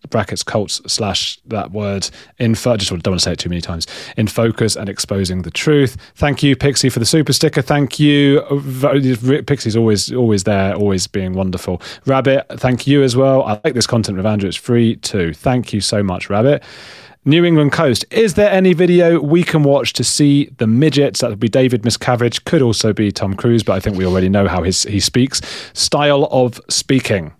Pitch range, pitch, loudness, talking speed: 100-140 Hz, 120 Hz, -15 LUFS, 200 wpm